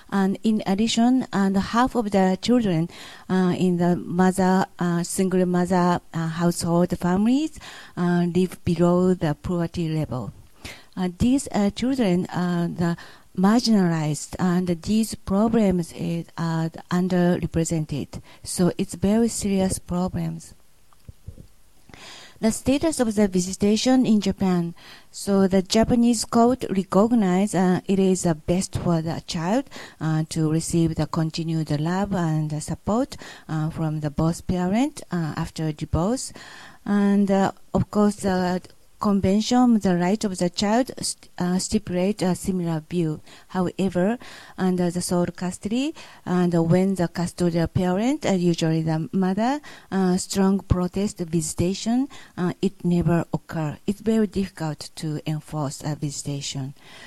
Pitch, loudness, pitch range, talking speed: 180 Hz, -23 LUFS, 170-200 Hz, 130 wpm